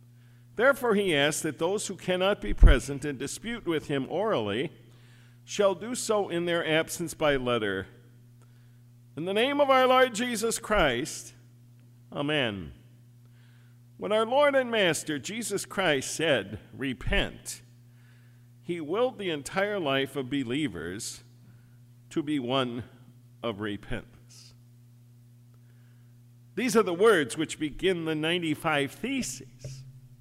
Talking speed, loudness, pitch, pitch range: 120 wpm, -28 LUFS, 130 Hz, 120-170 Hz